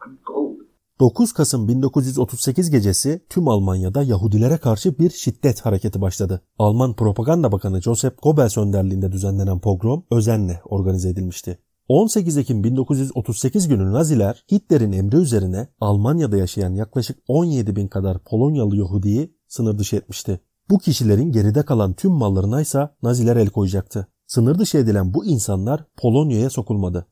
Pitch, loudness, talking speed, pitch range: 115 Hz, -19 LUFS, 130 wpm, 100-145 Hz